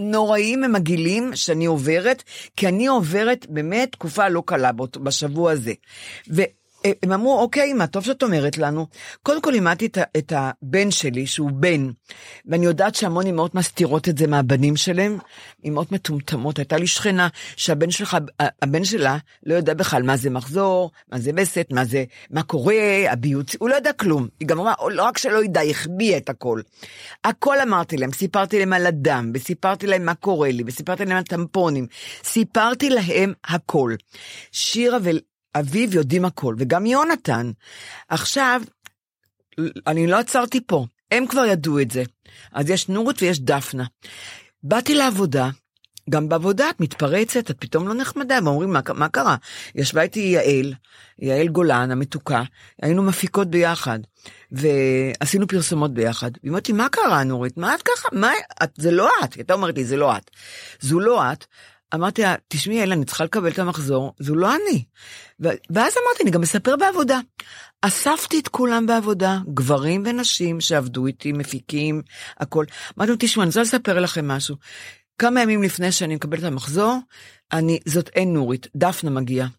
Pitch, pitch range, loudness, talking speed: 170 Hz, 145-205 Hz, -20 LUFS, 165 wpm